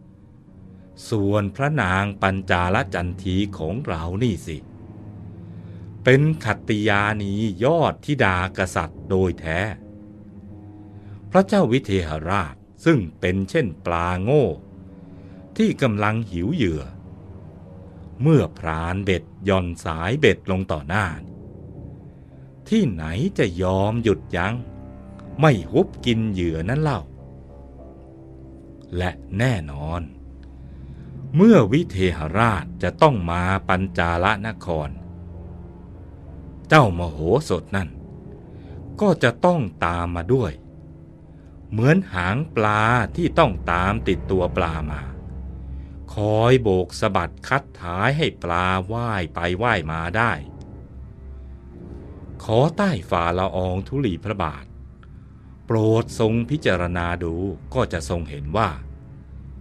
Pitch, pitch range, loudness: 95 Hz, 85-110 Hz, -21 LUFS